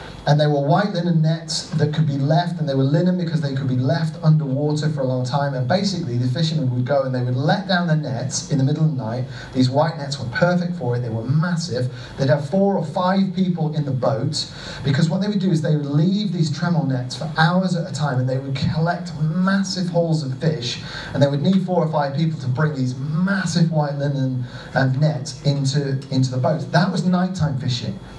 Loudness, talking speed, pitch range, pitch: -20 LUFS, 235 wpm, 135-170 Hz, 150 Hz